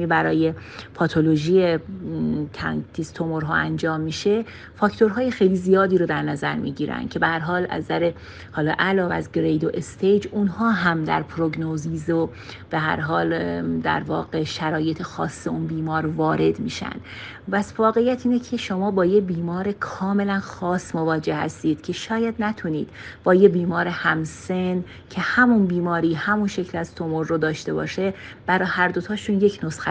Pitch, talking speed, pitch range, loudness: 170 Hz, 145 wpm, 160-195 Hz, -22 LUFS